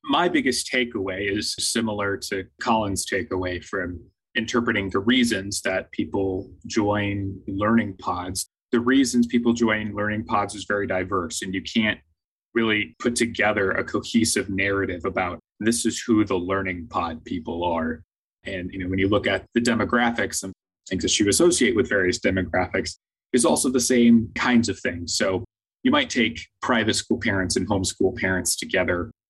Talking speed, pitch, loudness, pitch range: 160 wpm, 105 Hz, -23 LUFS, 95-115 Hz